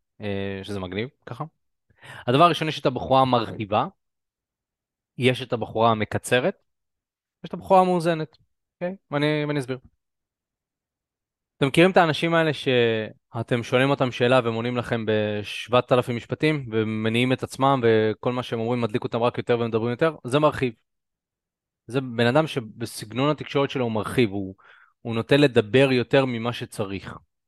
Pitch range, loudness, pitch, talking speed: 110-140 Hz, -23 LUFS, 120 Hz, 145 wpm